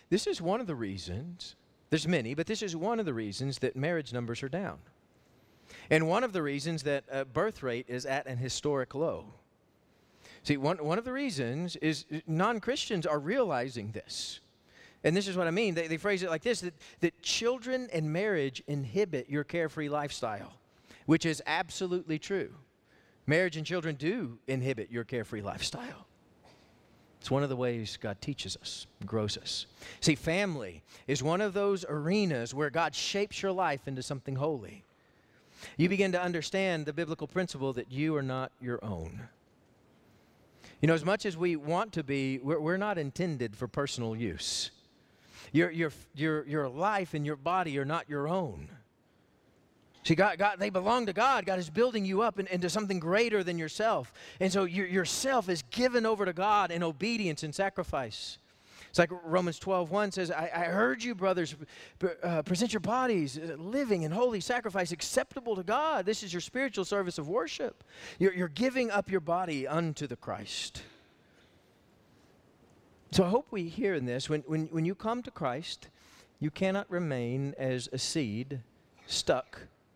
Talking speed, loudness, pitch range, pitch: 175 wpm, -32 LUFS, 135-195 Hz, 165 Hz